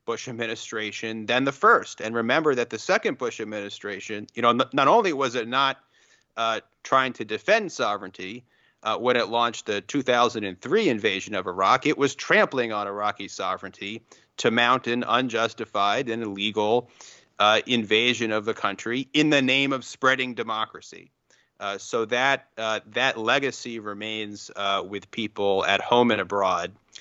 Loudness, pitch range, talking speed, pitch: -24 LUFS, 105-125 Hz, 155 wpm, 115 Hz